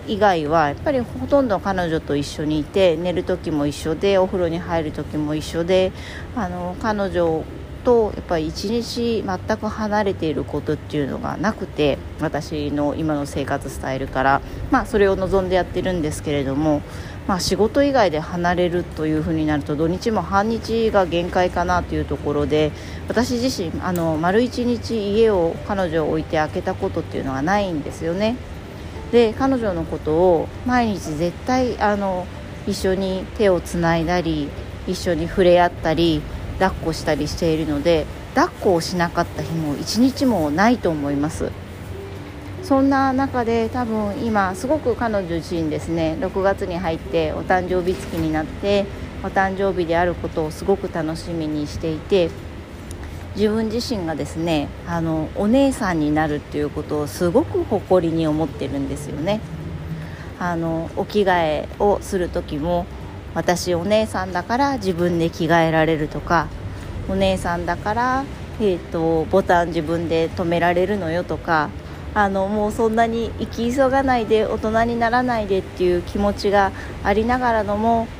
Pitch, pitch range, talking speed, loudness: 175 Hz, 155-205 Hz, 320 characters per minute, -21 LUFS